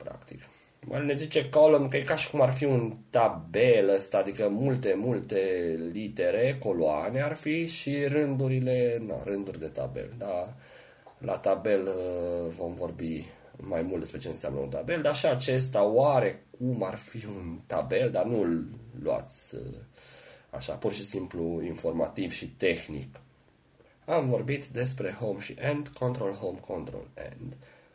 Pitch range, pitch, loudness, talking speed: 90-145 Hz, 125 Hz, -29 LUFS, 145 wpm